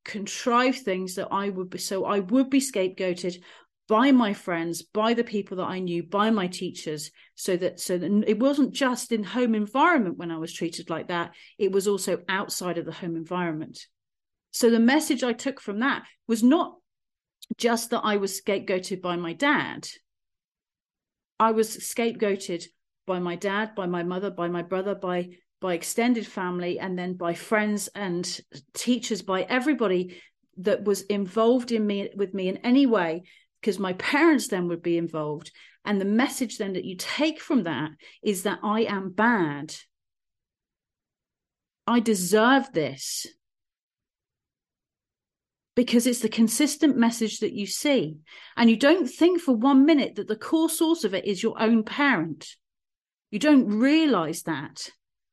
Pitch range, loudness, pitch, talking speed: 180-240 Hz, -25 LUFS, 205 Hz, 165 wpm